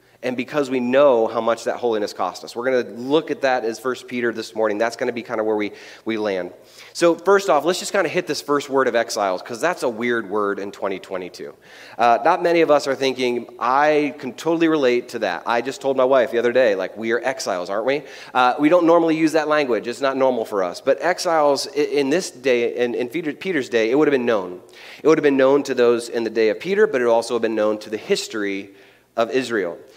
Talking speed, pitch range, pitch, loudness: 250 wpm, 115-155 Hz, 130 Hz, -20 LUFS